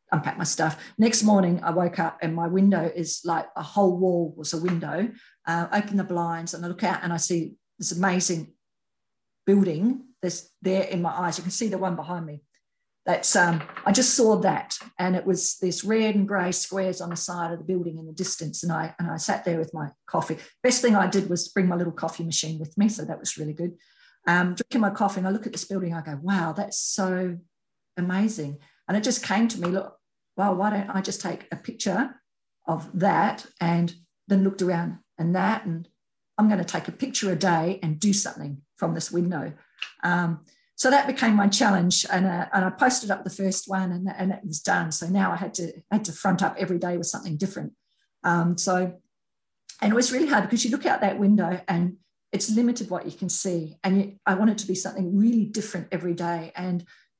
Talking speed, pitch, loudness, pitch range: 230 wpm, 185 Hz, -25 LUFS, 170-200 Hz